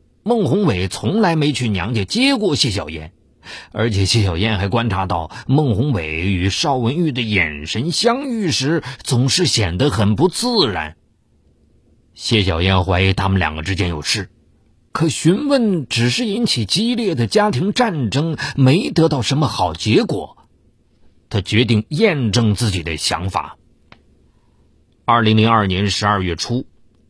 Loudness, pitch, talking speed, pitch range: -17 LUFS, 115 Hz, 215 characters per minute, 95-150 Hz